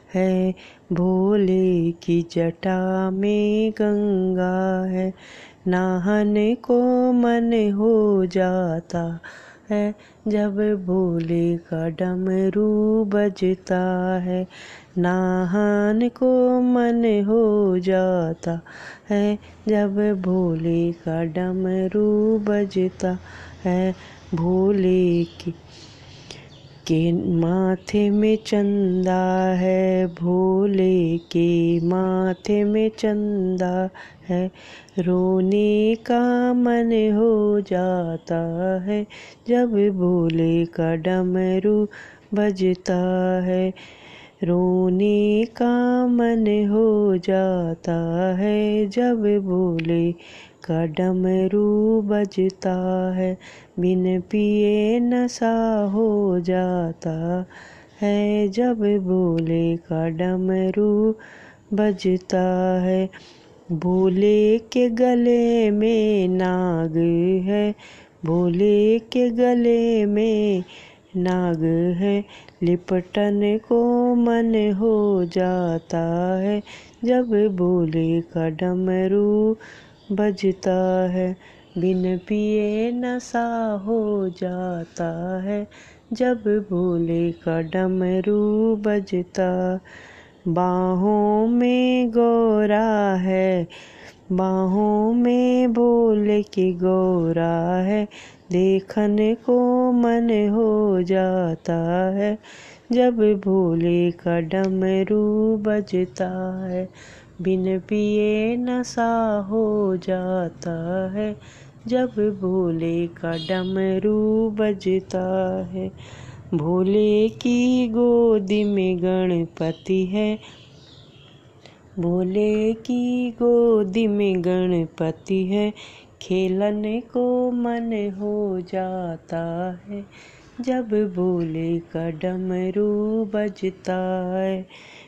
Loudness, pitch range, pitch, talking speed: -21 LUFS, 180-210 Hz, 190 Hz, 75 wpm